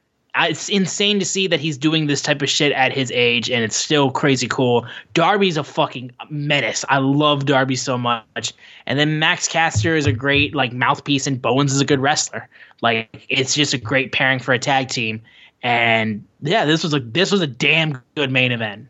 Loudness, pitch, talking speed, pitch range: -18 LUFS, 140 Hz, 205 wpm, 125-150 Hz